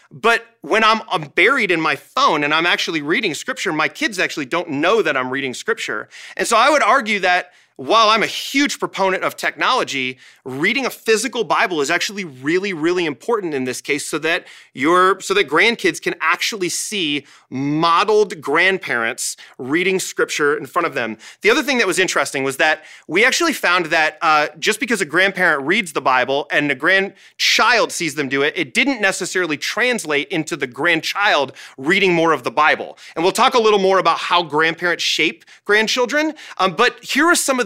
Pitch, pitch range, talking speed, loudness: 190 Hz, 160-235 Hz, 190 wpm, -17 LUFS